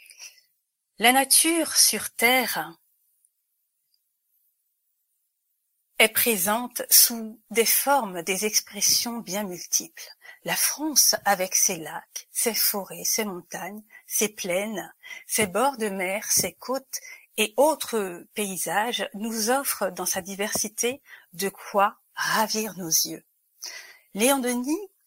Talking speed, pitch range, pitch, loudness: 110 wpm, 200-265 Hz, 220 Hz, -23 LUFS